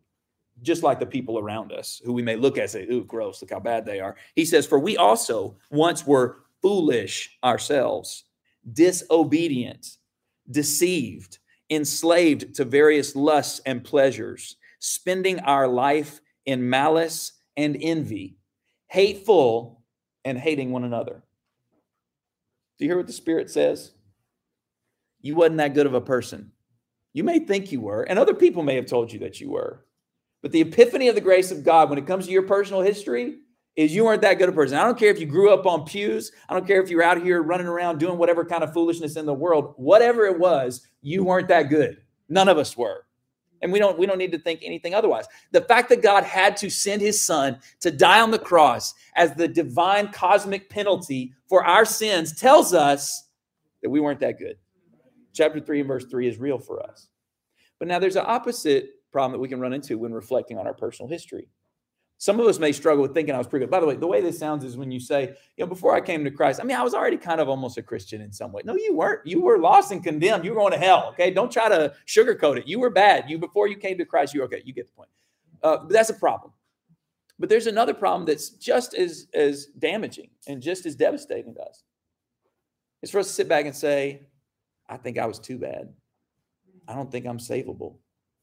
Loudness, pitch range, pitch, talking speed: -21 LUFS, 140-200 Hz, 165 Hz, 215 wpm